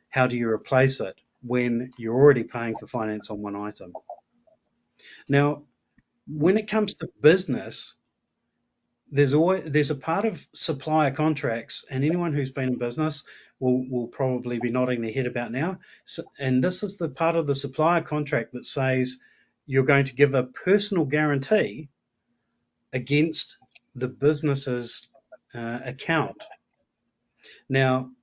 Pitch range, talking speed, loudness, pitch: 125-155 Hz, 145 wpm, -25 LUFS, 140 Hz